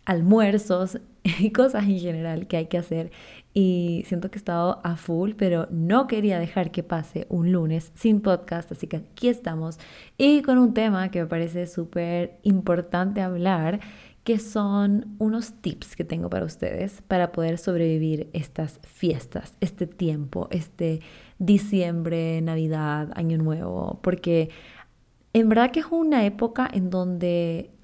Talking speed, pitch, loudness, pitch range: 150 wpm, 180 Hz, -24 LUFS, 165-205 Hz